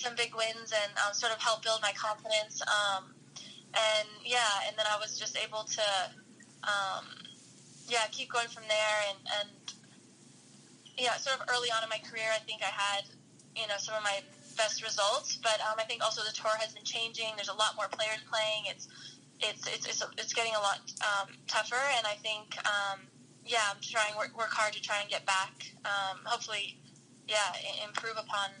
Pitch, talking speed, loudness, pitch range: 215 Hz, 195 wpm, -32 LUFS, 205-225 Hz